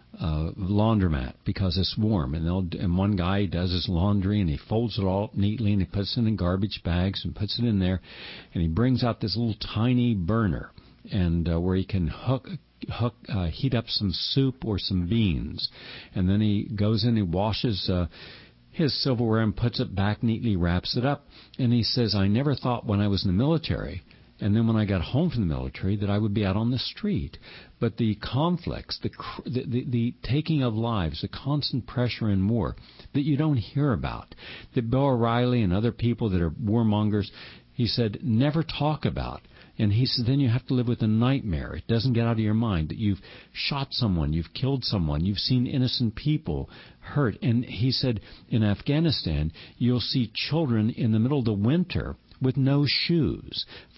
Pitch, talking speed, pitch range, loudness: 110 Hz, 200 wpm, 95-125 Hz, -26 LUFS